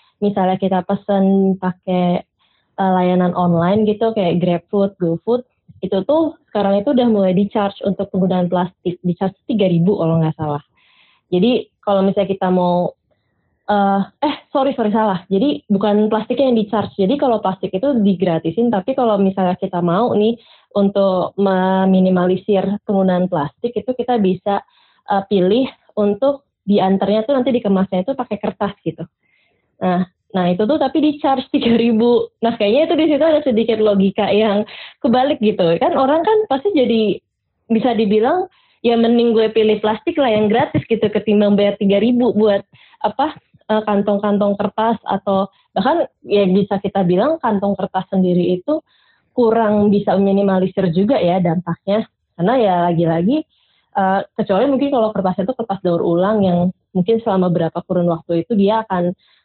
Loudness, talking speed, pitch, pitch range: -17 LUFS, 150 wpm, 200 Hz, 185-230 Hz